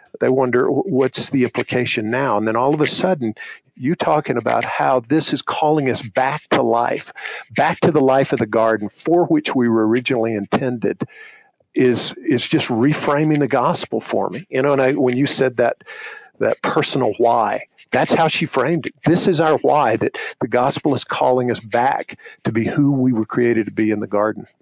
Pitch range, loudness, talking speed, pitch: 115-140 Hz, -18 LUFS, 200 wpm, 125 Hz